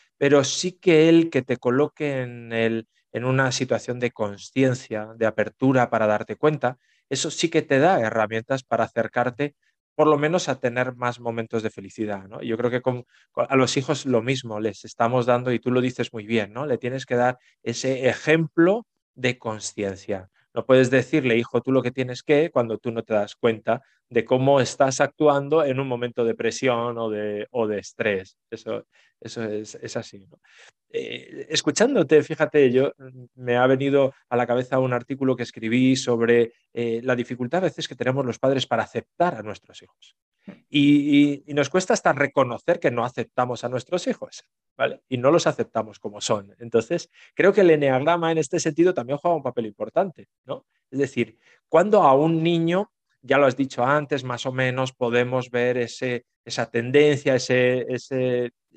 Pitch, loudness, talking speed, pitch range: 125 Hz, -23 LUFS, 190 wpm, 120-145 Hz